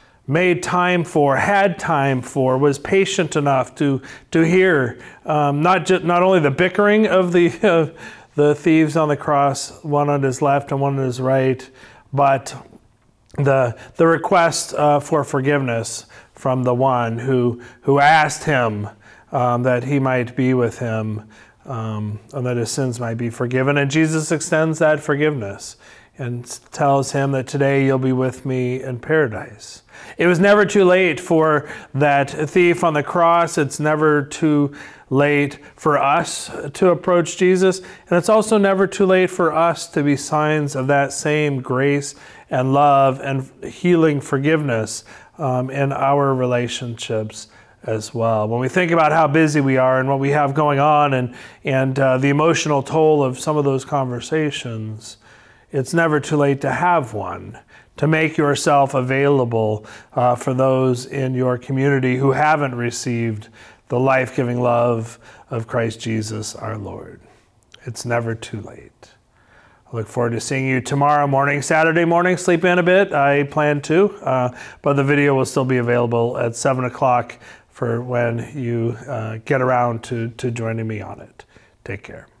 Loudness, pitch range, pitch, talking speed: -18 LUFS, 125-155 Hz, 140 Hz, 165 wpm